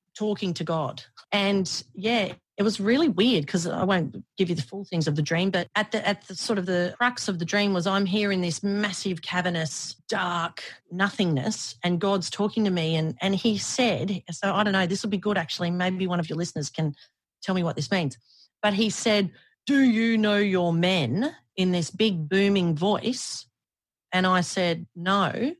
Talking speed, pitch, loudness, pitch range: 205 wpm, 190 Hz, -25 LUFS, 170-205 Hz